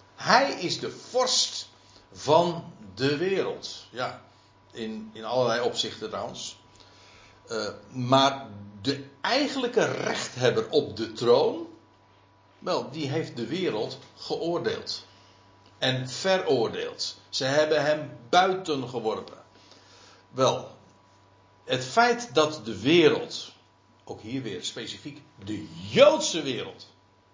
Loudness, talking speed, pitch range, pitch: -26 LUFS, 100 wpm, 100-160 Hz, 130 Hz